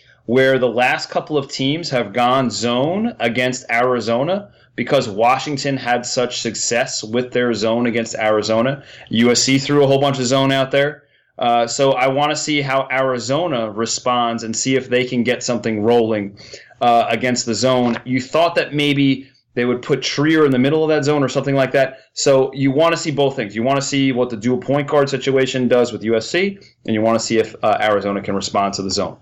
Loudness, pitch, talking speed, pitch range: -17 LUFS, 125 Hz, 210 wpm, 115-140 Hz